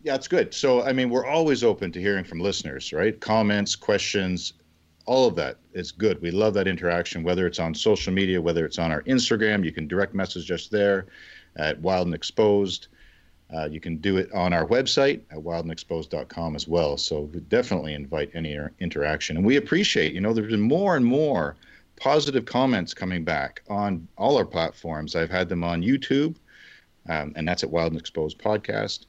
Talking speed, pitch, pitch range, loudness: 195 wpm, 90 Hz, 80-105 Hz, -24 LUFS